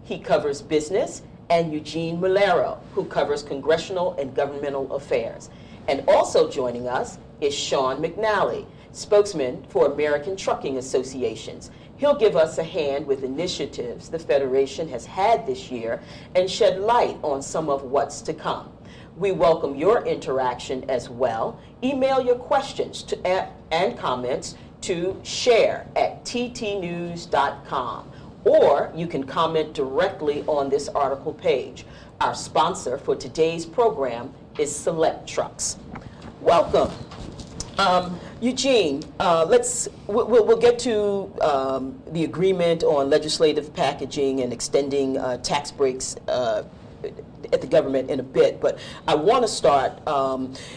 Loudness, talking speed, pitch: -23 LUFS, 135 wpm, 175 Hz